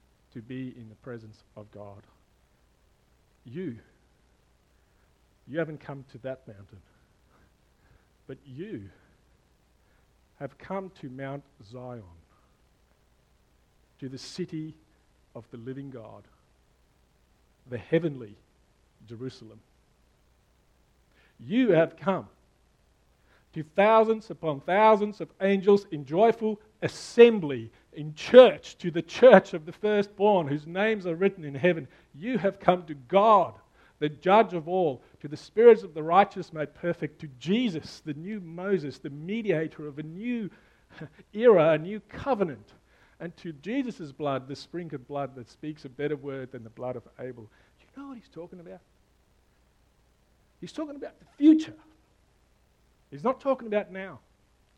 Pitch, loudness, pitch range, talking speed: 155 Hz, -25 LUFS, 125-195 Hz, 135 wpm